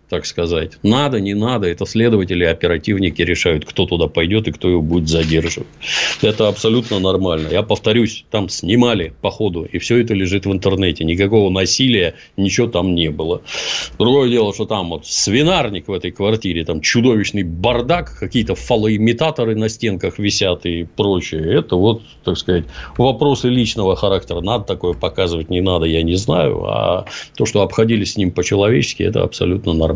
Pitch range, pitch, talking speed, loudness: 85-110 Hz, 100 Hz, 165 wpm, -16 LUFS